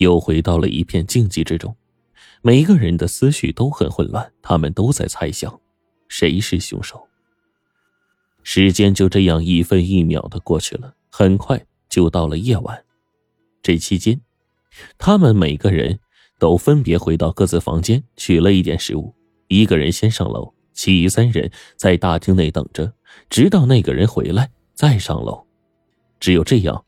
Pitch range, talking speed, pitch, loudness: 85-110 Hz, 230 characters per minute, 95 Hz, -17 LUFS